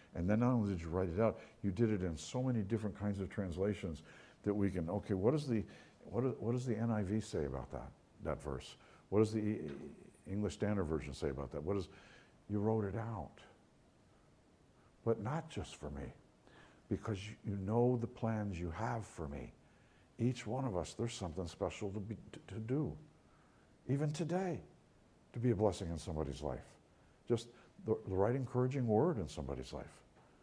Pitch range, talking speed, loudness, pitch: 85-115 Hz, 185 wpm, -39 LUFS, 105 Hz